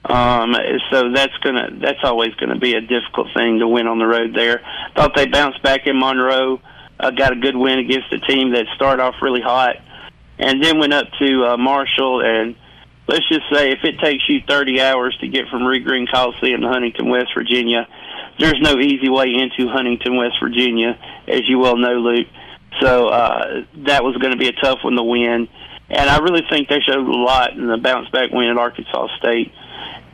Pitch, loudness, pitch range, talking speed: 130 Hz, -16 LUFS, 120-135 Hz, 205 wpm